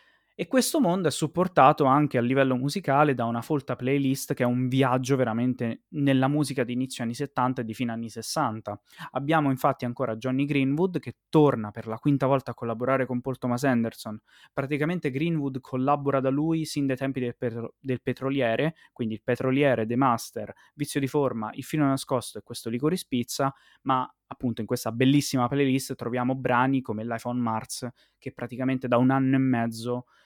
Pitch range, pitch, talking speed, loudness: 120-140 Hz, 130 Hz, 180 wpm, -26 LUFS